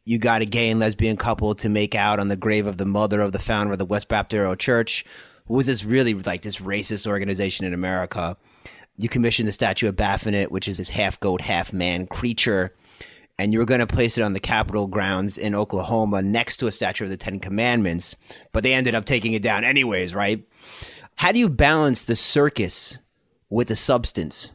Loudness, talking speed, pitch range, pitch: -22 LUFS, 215 wpm, 100-115 Hz, 105 Hz